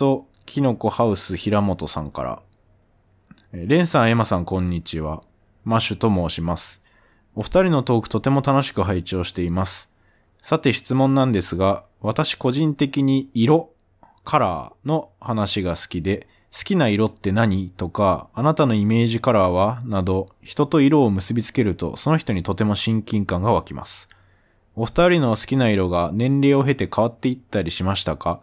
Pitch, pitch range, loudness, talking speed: 105 Hz, 95-130 Hz, -21 LUFS, 310 characters per minute